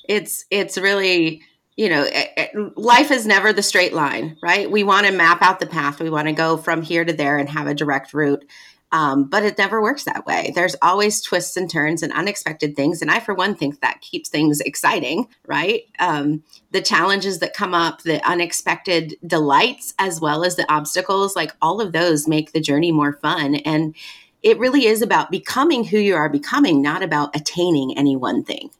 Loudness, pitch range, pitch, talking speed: -18 LUFS, 155-205 Hz, 175 Hz, 205 wpm